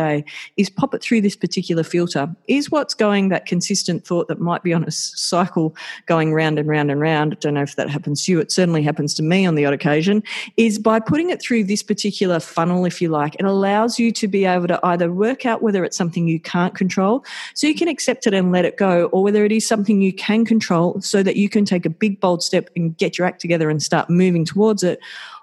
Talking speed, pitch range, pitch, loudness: 250 wpm, 165-210 Hz, 180 Hz, -18 LUFS